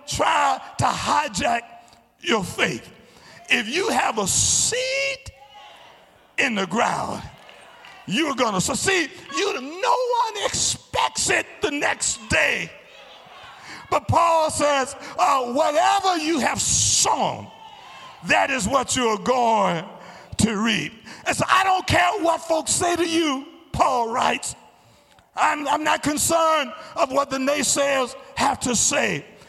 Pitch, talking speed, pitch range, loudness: 305 Hz, 130 wpm, 270-345 Hz, -21 LUFS